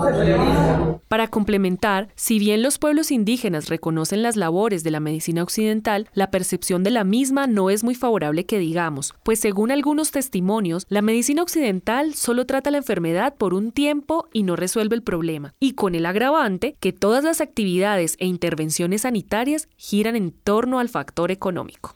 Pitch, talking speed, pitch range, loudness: 210 Hz, 165 wpm, 180-245 Hz, -21 LUFS